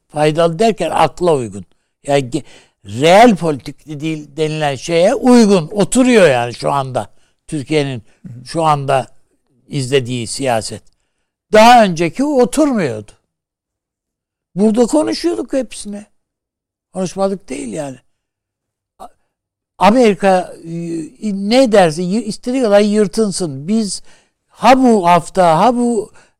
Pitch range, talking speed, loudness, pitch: 135-215 Hz, 95 wpm, -14 LUFS, 165 Hz